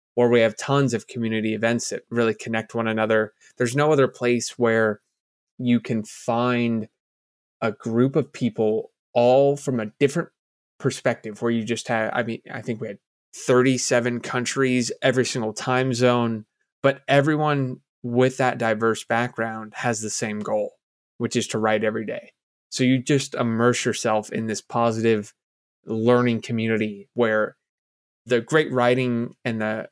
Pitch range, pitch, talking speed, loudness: 110-125 Hz, 120 Hz, 155 wpm, -23 LUFS